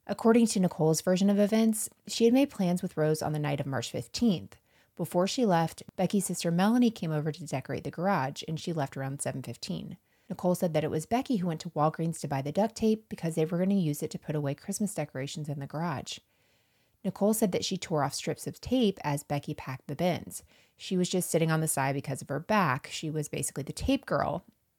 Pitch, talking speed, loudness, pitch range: 165 Hz, 230 wpm, -30 LUFS, 145-195 Hz